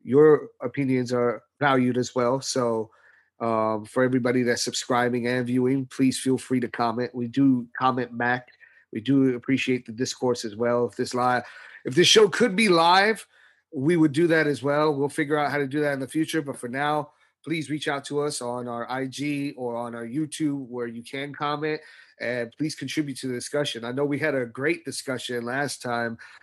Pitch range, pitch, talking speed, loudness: 120-145 Hz, 130 Hz, 200 wpm, -25 LUFS